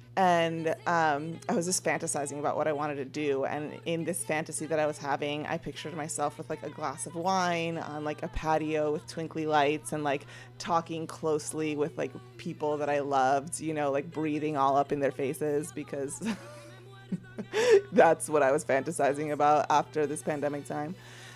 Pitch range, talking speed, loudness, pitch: 145-160 Hz, 185 wpm, -30 LUFS, 150 Hz